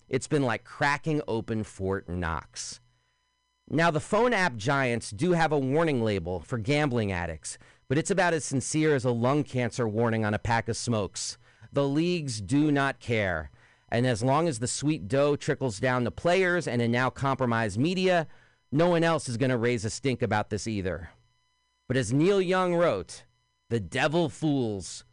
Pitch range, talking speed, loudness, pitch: 115-155 Hz, 180 wpm, -27 LUFS, 130 Hz